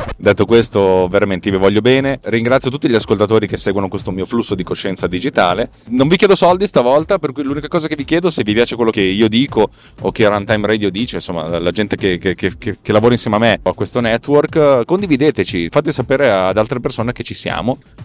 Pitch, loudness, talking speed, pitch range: 115 Hz, -14 LUFS, 225 wpm, 100-140 Hz